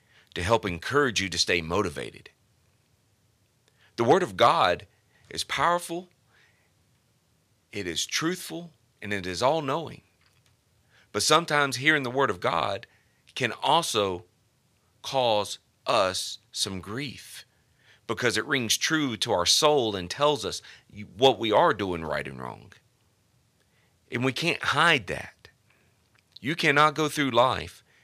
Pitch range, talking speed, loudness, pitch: 105-145 Hz, 130 wpm, -25 LUFS, 120 Hz